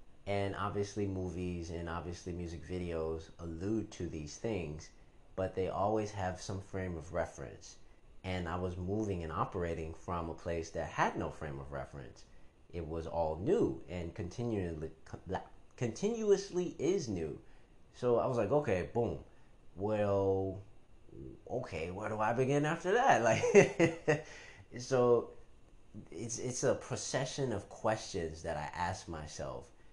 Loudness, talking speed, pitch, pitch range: -36 LUFS, 135 wpm, 95 Hz, 85-110 Hz